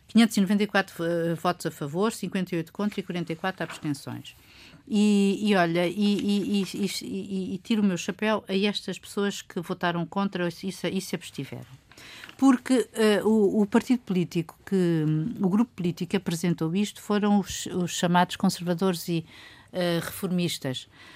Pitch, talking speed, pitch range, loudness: 190 Hz, 155 wpm, 175-205 Hz, -26 LUFS